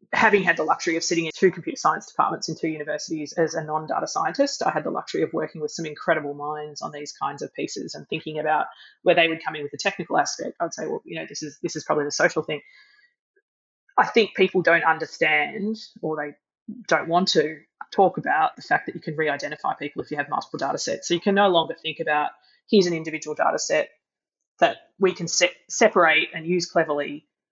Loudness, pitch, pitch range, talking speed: -23 LUFS, 165 Hz, 155-190 Hz, 230 wpm